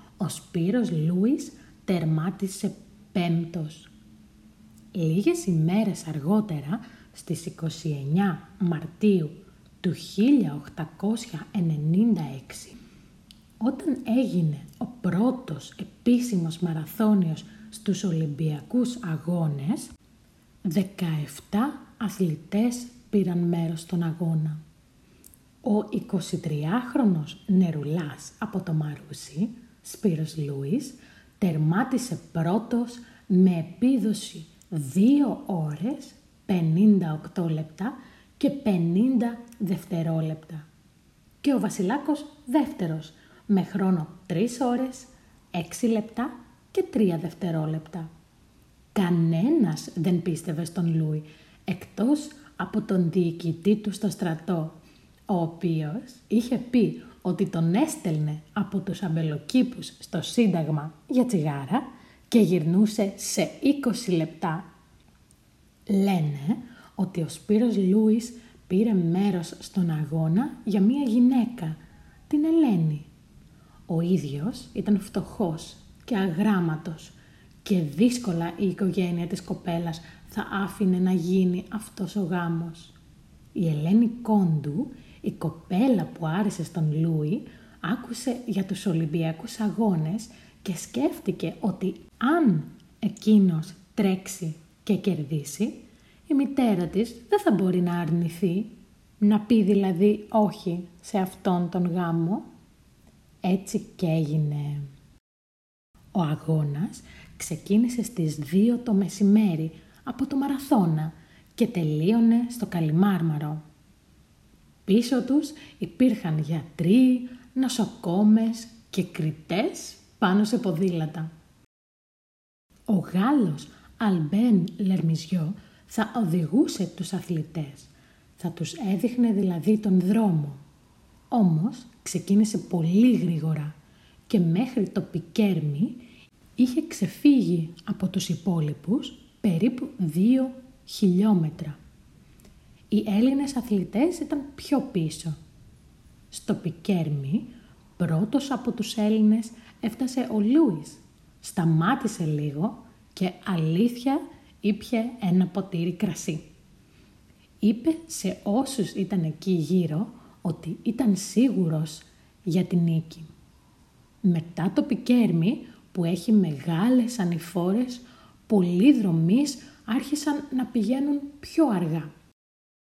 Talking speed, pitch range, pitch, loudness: 95 wpm, 170-230 Hz, 195 Hz, -26 LUFS